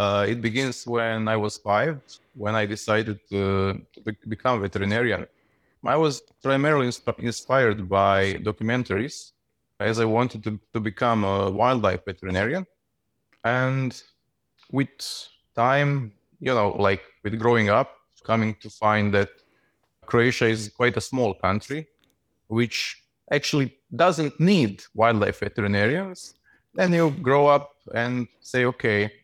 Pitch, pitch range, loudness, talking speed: 115 Hz, 105-130 Hz, -24 LUFS, 130 wpm